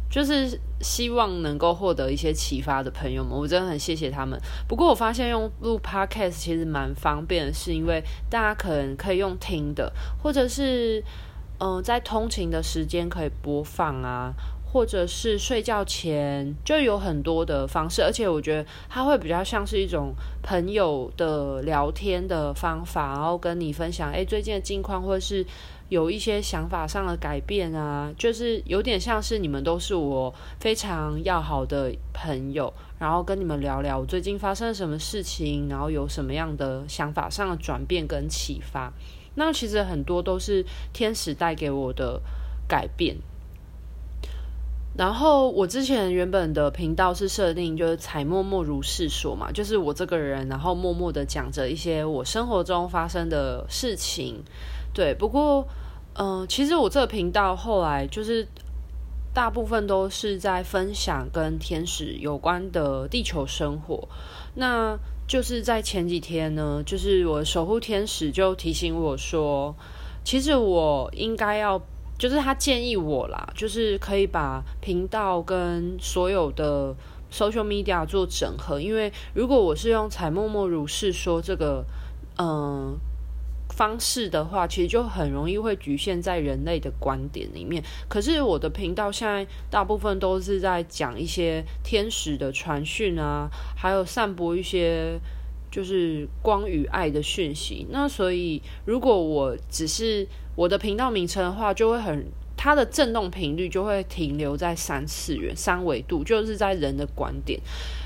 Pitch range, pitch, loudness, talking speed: 150-205 Hz, 175 Hz, -26 LUFS, 250 characters per minute